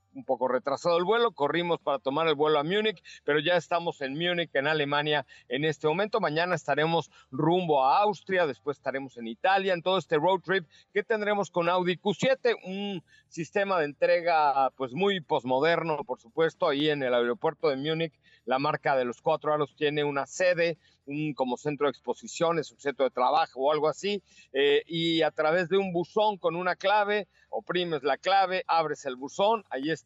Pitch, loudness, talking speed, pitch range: 160 Hz, -27 LUFS, 190 wpm, 145-185 Hz